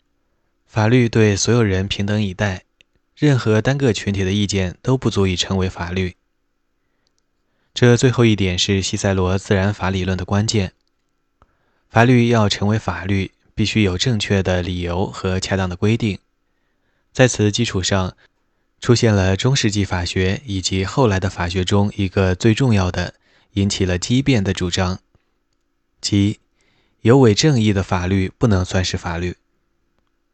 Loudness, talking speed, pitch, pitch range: -18 LUFS, 225 characters per minute, 100 Hz, 95-110 Hz